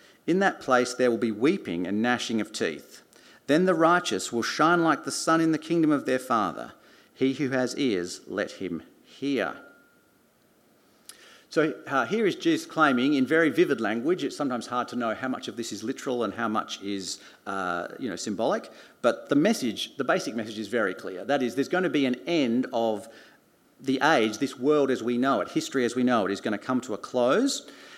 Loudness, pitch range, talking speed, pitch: -26 LUFS, 115-160 Hz, 210 wpm, 130 Hz